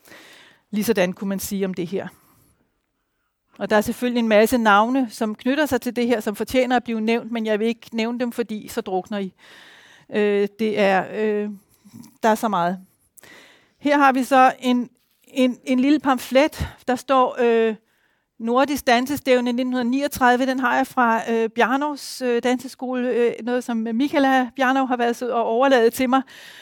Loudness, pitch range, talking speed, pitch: -21 LUFS, 220-255 Hz, 175 wpm, 240 Hz